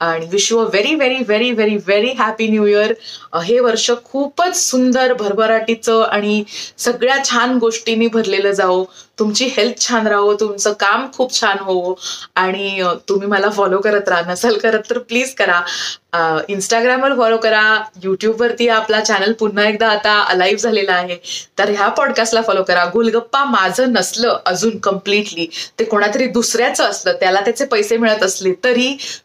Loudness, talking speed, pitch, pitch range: -15 LUFS, 150 wpm, 215 Hz, 200-235 Hz